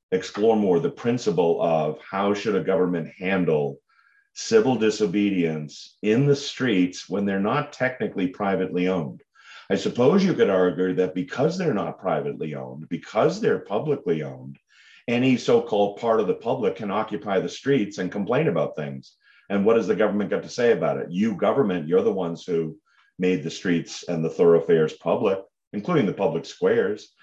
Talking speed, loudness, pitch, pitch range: 170 wpm, -23 LUFS, 100 Hz, 90-130 Hz